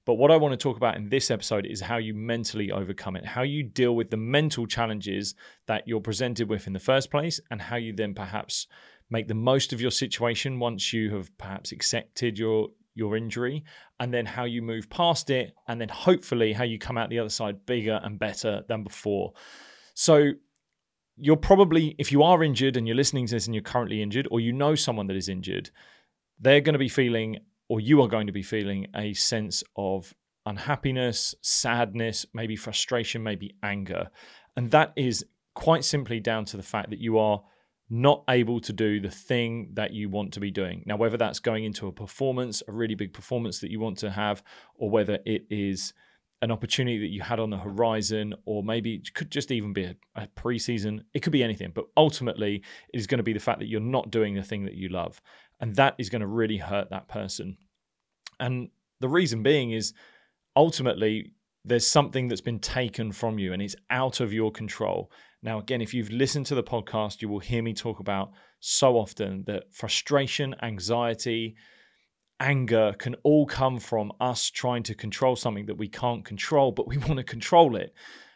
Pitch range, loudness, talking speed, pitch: 105-130 Hz, -27 LUFS, 205 wpm, 115 Hz